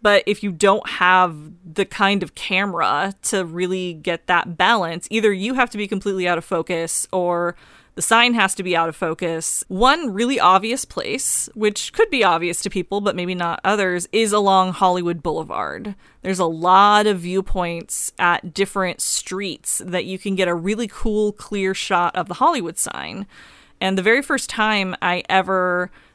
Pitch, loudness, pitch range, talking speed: 190 Hz, -19 LUFS, 175-205 Hz, 180 wpm